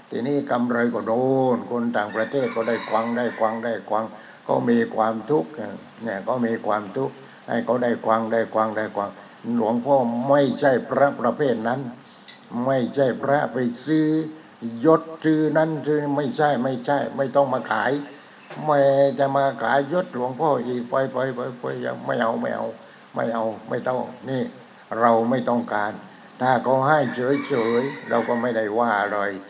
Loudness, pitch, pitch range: -23 LUFS, 125 Hz, 115-140 Hz